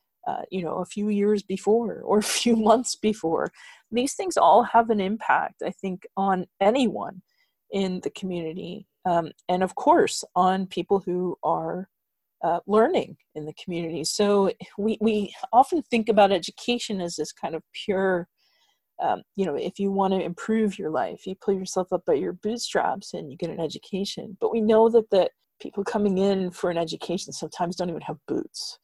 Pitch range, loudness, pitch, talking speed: 180-220 Hz, -25 LUFS, 195 Hz, 185 wpm